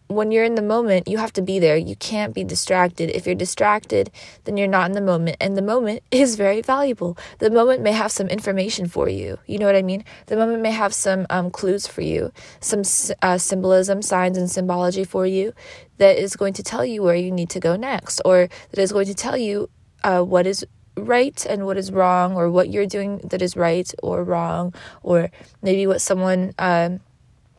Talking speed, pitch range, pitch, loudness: 215 wpm, 180-210 Hz, 195 Hz, -20 LUFS